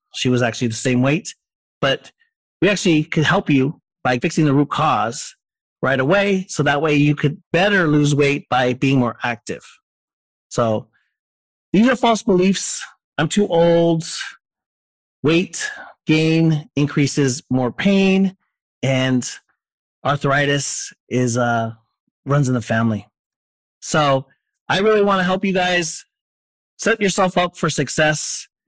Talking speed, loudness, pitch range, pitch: 135 wpm, -18 LUFS, 130-185 Hz, 150 Hz